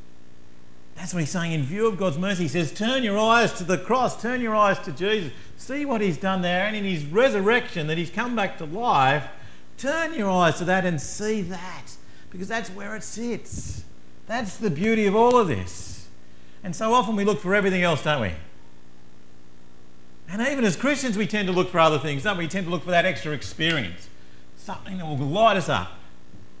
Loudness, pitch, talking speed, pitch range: -23 LUFS, 185 Hz, 210 wpm, 140-215 Hz